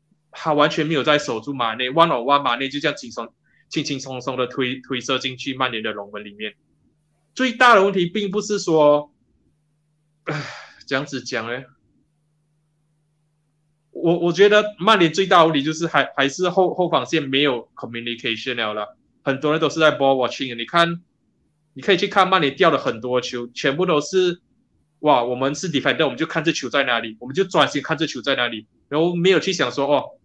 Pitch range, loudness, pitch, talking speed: 130-165 Hz, -20 LUFS, 150 Hz, 335 characters per minute